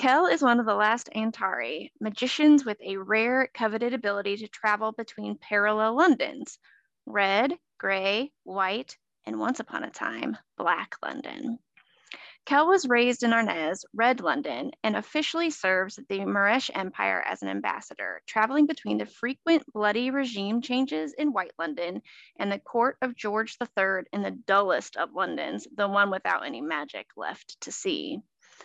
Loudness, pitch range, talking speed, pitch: -27 LUFS, 200-265 Hz, 155 wpm, 225 Hz